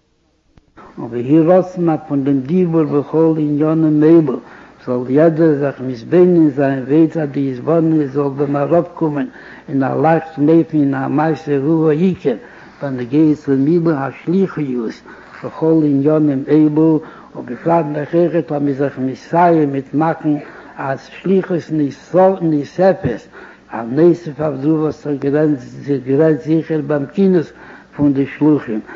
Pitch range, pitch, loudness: 140-160 Hz, 150 Hz, -15 LUFS